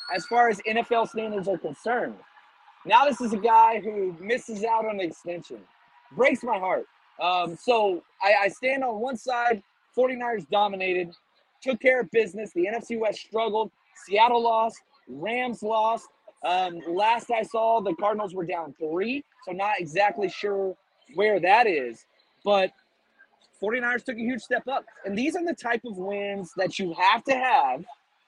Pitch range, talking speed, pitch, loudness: 195-240 Hz, 165 wpm, 225 Hz, -25 LUFS